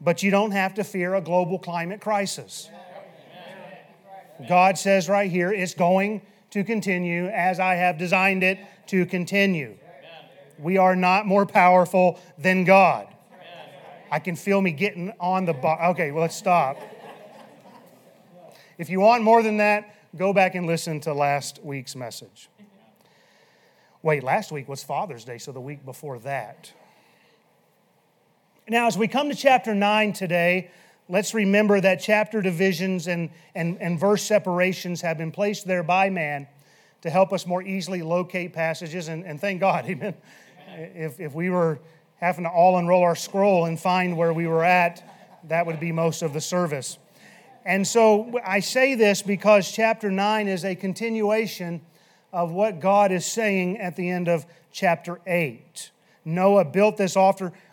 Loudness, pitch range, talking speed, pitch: -22 LUFS, 170-200 Hz, 160 wpm, 185 Hz